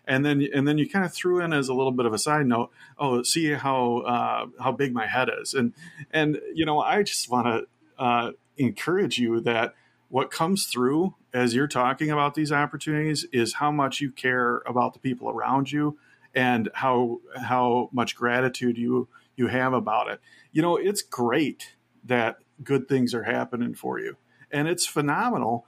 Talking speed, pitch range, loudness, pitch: 190 wpm, 125-150 Hz, -25 LUFS, 135 Hz